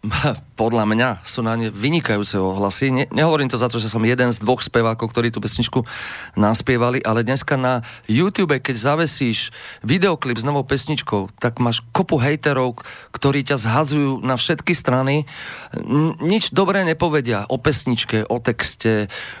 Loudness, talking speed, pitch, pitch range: -19 LUFS, 150 wpm, 125 Hz, 115-145 Hz